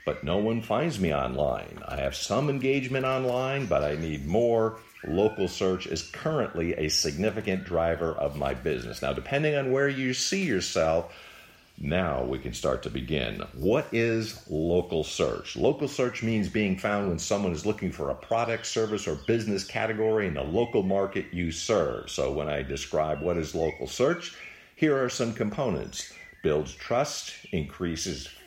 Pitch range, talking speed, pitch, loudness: 85-120 Hz, 165 wpm, 110 Hz, -28 LUFS